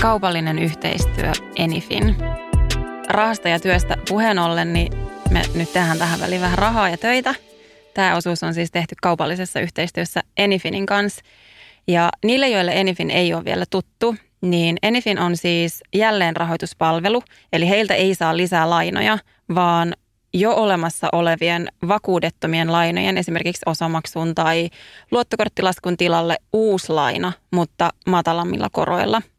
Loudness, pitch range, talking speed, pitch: -19 LUFS, 165-195 Hz, 130 wpm, 175 Hz